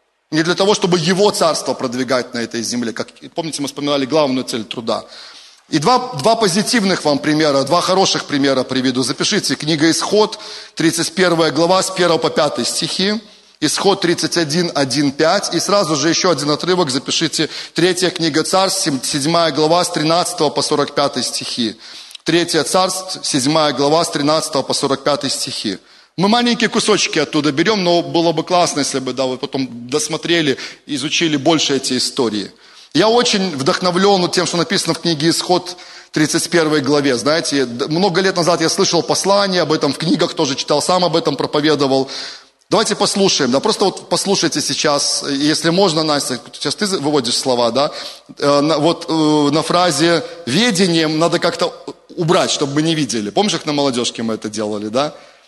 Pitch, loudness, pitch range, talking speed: 165 Hz, -16 LUFS, 145-180 Hz, 160 wpm